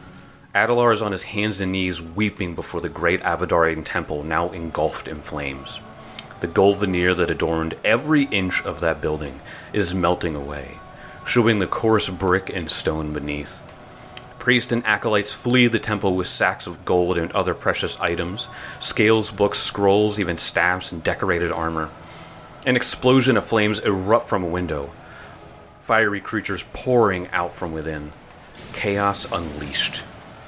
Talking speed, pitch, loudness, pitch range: 150 wpm, 95 Hz, -21 LUFS, 85-110 Hz